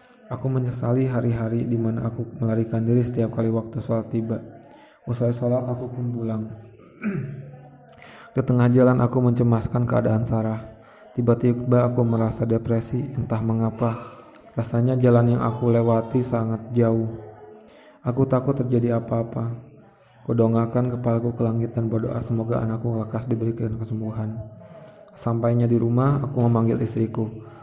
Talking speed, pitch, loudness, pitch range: 130 wpm, 115 Hz, -23 LUFS, 115-125 Hz